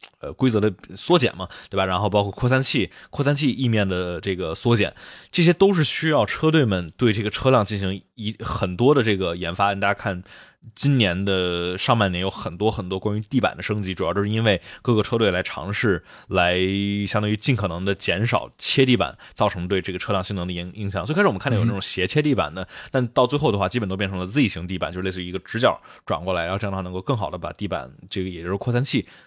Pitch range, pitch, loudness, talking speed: 95-120 Hz, 100 Hz, -22 LUFS, 360 characters per minute